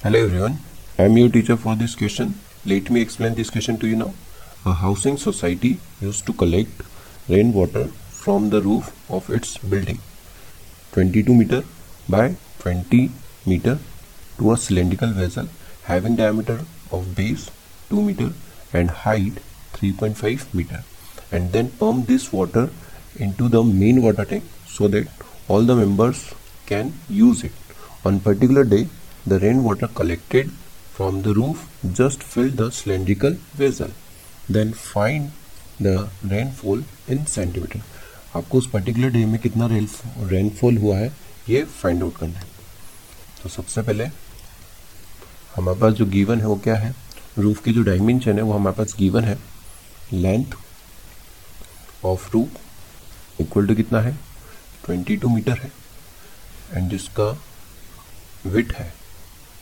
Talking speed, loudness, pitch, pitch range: 140 wpm, -20 LUFS, 105 Hz, 95-115 Hz